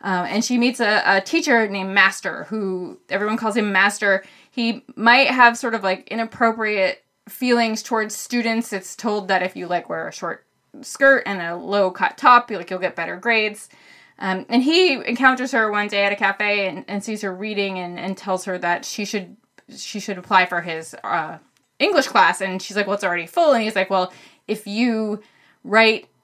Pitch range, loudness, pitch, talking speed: 190-230 Hz, -19 LUFS, 210 Hz, 205 wpm